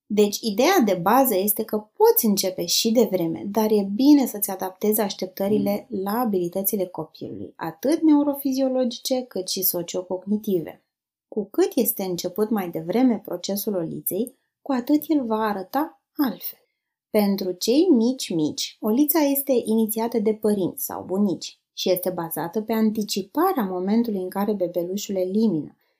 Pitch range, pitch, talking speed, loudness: 190-250 Hz, 215 Hz, 135 wpm, -23 LUFS